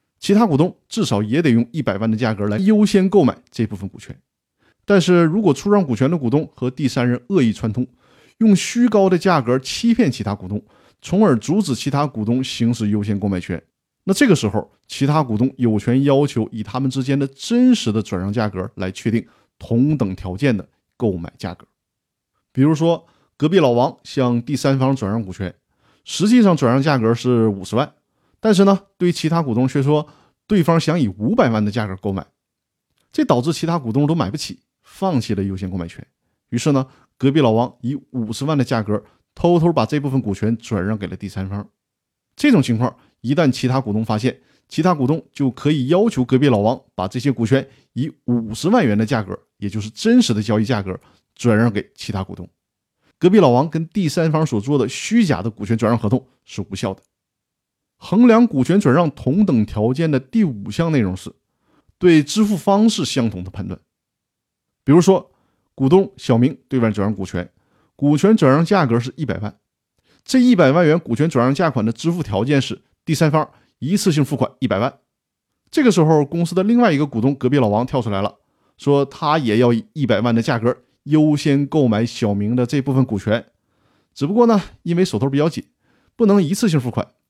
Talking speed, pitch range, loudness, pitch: 290 characters per minute, 110-160 Hz, -18 LUFS, 130 Hz